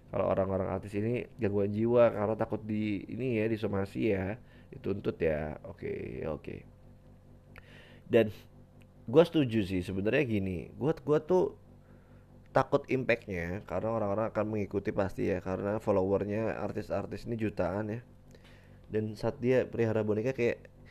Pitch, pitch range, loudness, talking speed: 110 Hz, 100-115 Hz, -32 LUFS, 140 wpm